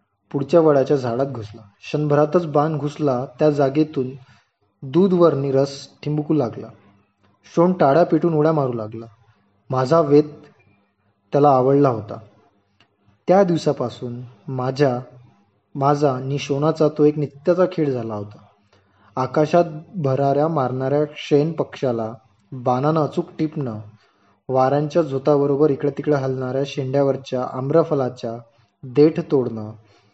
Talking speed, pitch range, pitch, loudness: 100 wpm, 115-150 Hz, 135 Hz, -20 LUFS